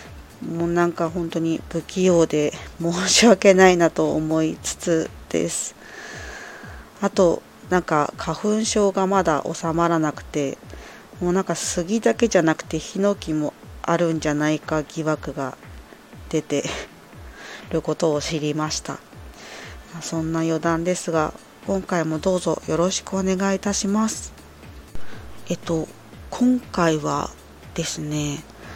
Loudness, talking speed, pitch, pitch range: -22 LUFS, 240 characters per minute, 165 Hz, 155-185 Hz